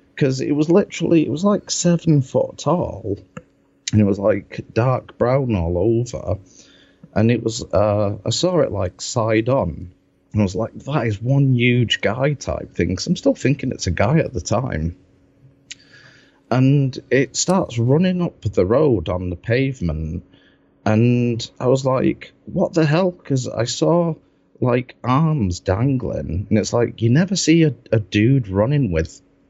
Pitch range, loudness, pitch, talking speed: 100-140 Hz, -19 LUFS, 120 Hz, 170 wpm